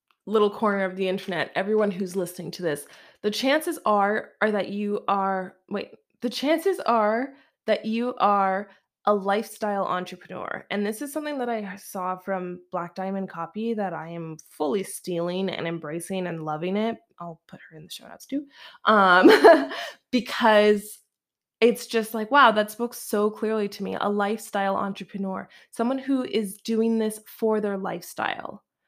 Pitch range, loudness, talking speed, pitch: 190-225 Hz, -24 LUFS, 165 wpm, 205 Hz